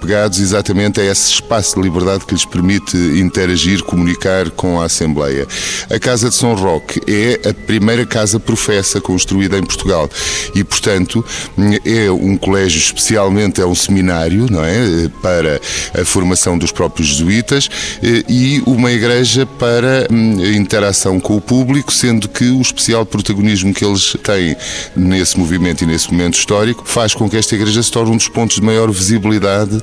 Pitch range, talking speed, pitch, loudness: 90-115 Hz, 160 wpm, 100 Hz, -12 LUFS